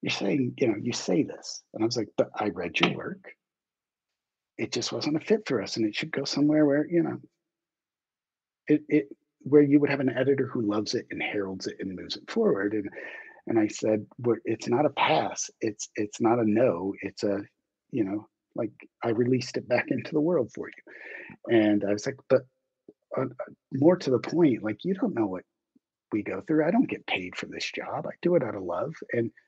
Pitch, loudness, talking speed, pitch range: 130 Hz, -27 LUFS, 225 wpm, 110-160 Hz